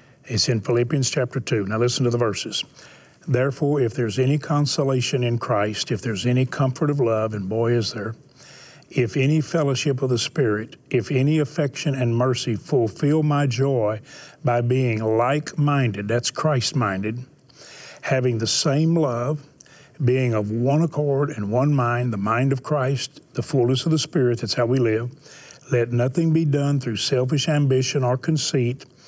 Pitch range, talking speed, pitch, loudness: 120-145 Hz, 165 wpm, 130 Hz, -22 LUFS